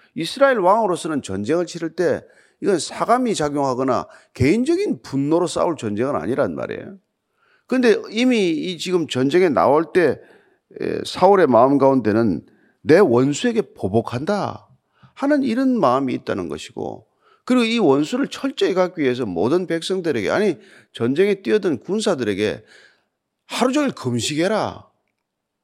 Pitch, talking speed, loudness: 185 Hz, 310 characters per minute, -19 LUFS